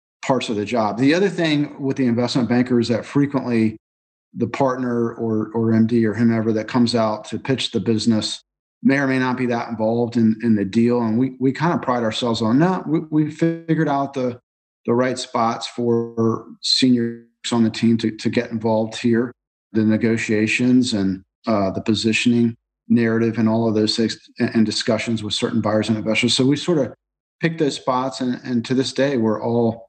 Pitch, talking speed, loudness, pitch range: 115 Hz, 200 wpm, -20 LUFS, 110-125 Hz